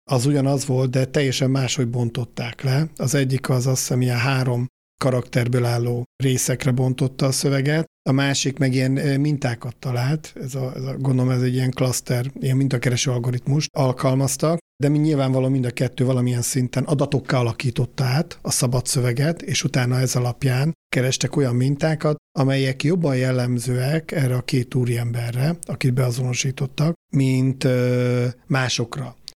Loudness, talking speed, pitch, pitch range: -21 LUFS, 150 wpm, 130 Hz, 125-140 Hz